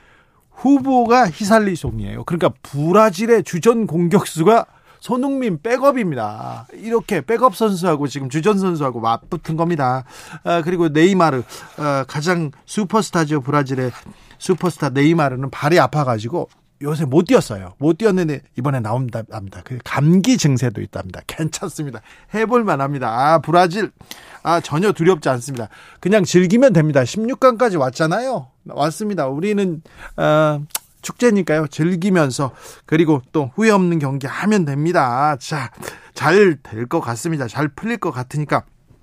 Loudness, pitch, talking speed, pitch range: -17 LUFS, 165 Hz, 320 characters per minute, 140-200 Hz